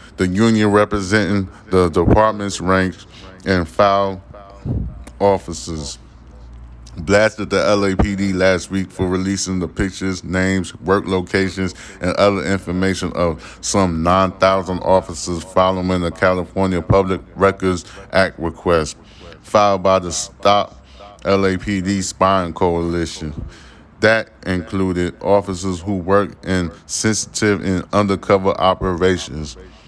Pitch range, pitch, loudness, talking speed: 90-100 Hz, 95 Hz, -18 LUFS, 105 wpm